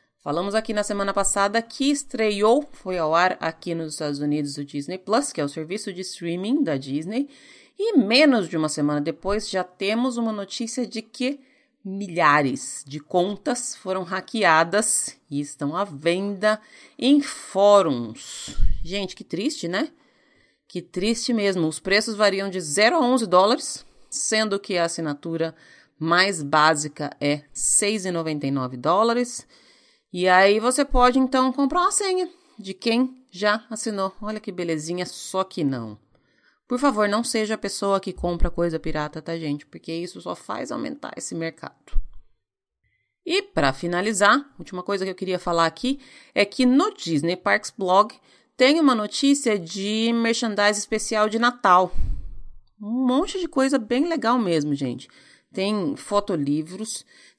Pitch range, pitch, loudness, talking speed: 165-240 Hz, 200 Hz, -23 LUFS, 150 wpm